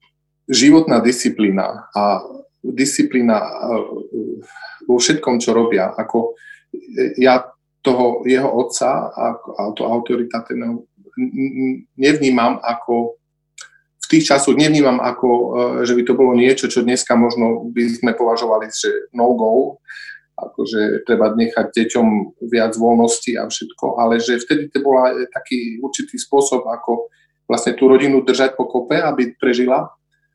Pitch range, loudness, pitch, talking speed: 115-150 Hz, -16 LUFS, 125 Hz, 125 wpm